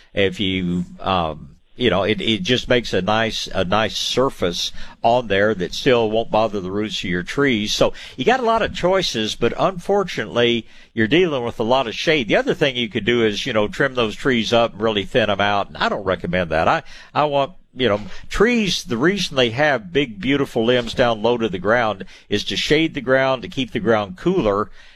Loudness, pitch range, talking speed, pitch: -19 LUFS, 105-140 Hz, 220 wpm, 120 Hz